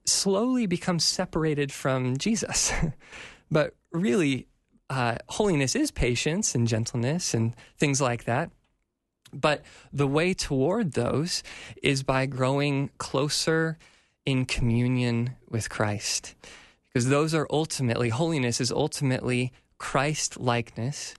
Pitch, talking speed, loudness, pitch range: 135 Hz, 110 wpm, -26 LUFS, 120-160 Hz